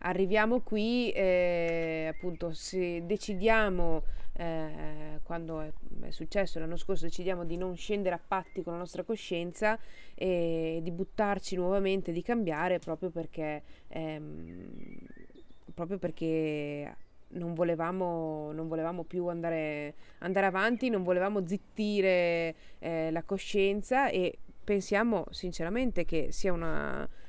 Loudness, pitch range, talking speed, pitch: -32 LUFS, 165-195 Hz, 120 wpm, 175 Hz